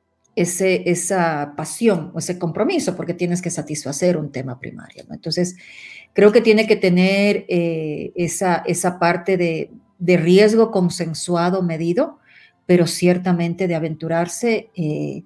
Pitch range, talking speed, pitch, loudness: 165-190 Hz, 135 wpm, 175 Hz, -19 LUFS